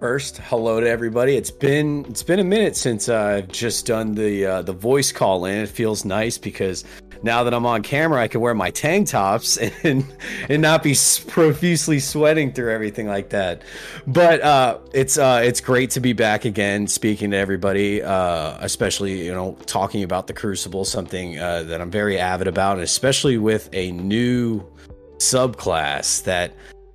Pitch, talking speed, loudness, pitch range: 110 Hz, 180 wpm, -20 LUFS, 95-135 Hz